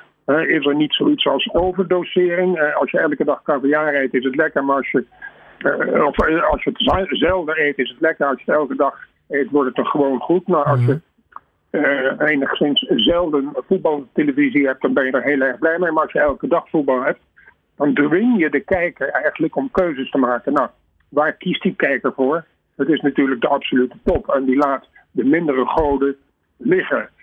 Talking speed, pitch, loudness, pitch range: 210 wpm, 150 Hz, -18 LUFS, 140-180 Hz